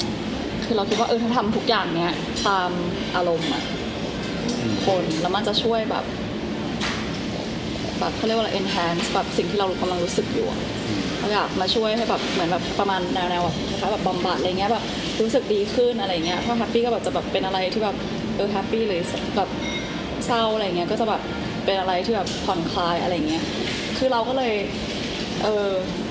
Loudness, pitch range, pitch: -23 LUFS, 185-230 Hz, 205 Hz